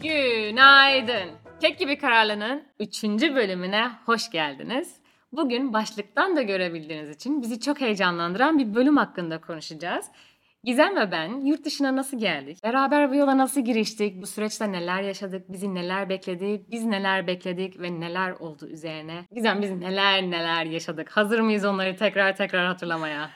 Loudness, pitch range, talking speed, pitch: -24 LUFS, 180-260 Hz, 145 wpm, 205 Hz